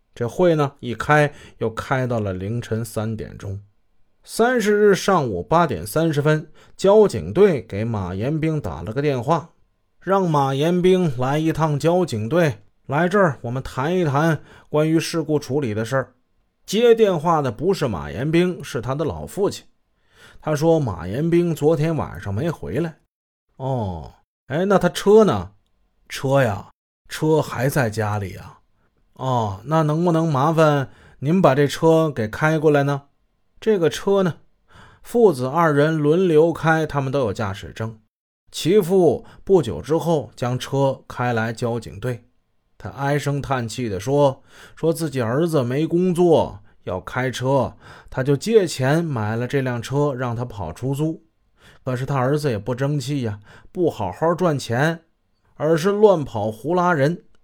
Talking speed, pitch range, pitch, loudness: 215 characters per minute, 115-165 Hz, 140 Hz, -20 LUFS